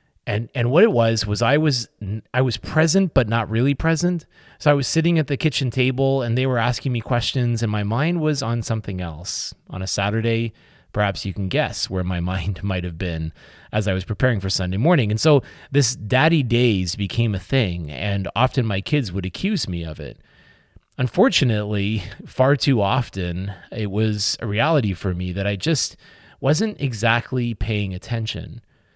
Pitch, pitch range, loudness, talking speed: 115 Hz, 100-135 Hz, -21 LUFS, 185 wpm